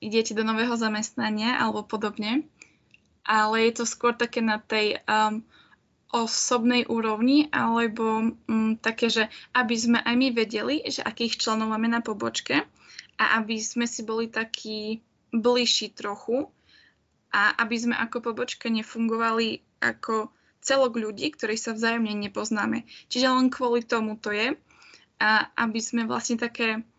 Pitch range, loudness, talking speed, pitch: 220-240 Hz, -25 LUFS, 140 wpm, 230 Hz